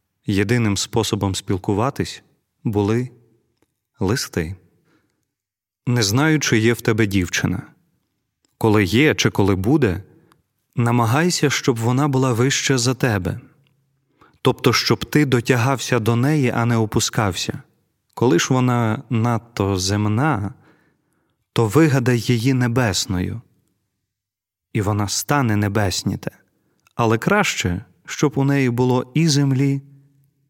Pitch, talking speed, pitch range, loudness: 120 Hz, 105 wpm, 105-135 Hz, -19 LUFS